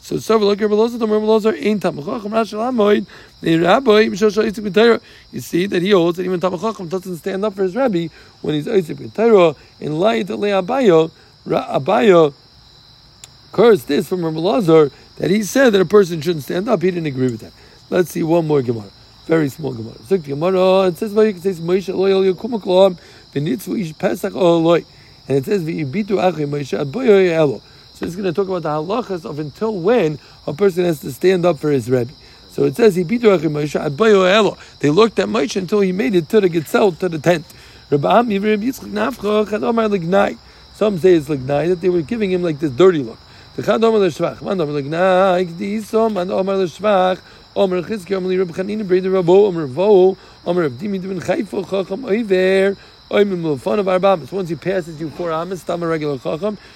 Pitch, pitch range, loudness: 185 Hz, 160-205 Hz, -17 LUFS